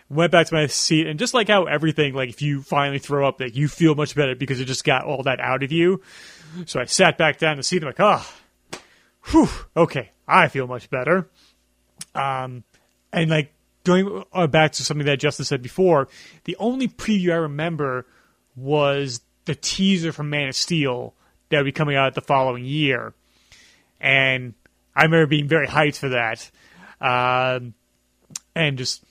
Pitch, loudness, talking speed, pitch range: 145 Hz, -20 LUFS, 185 wpm, 130-165 Hz